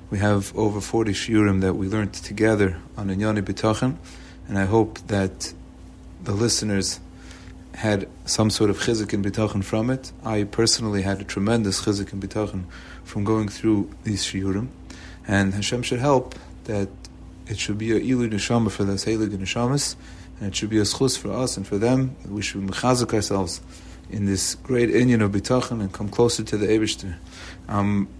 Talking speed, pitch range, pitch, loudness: 175 wpm, 95-110 Hz, 100 Hz, -23 LUFS